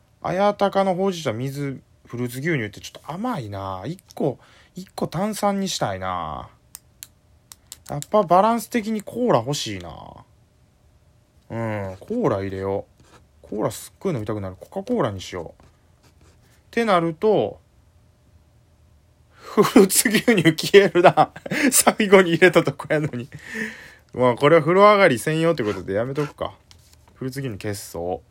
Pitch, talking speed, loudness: 145 Hz, 285 characters per minute, -20 LUFS